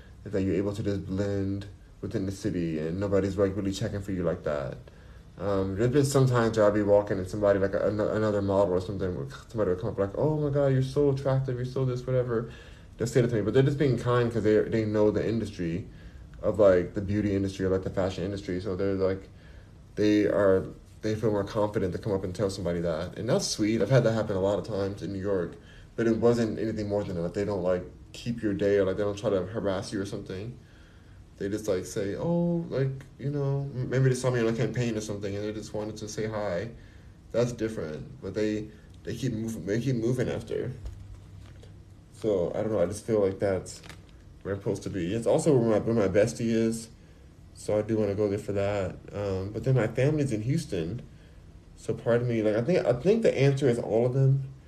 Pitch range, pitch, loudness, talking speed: 95-115 Hz, 105 Hz, -28 LUFS, 240 wpm